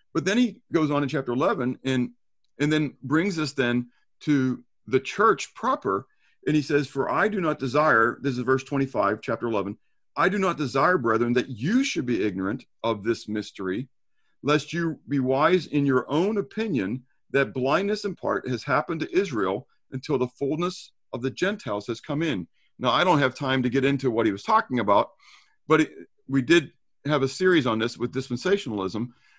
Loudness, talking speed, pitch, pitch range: -25 LUFS, 190 wpm, 135 Hz, 120-155 Hz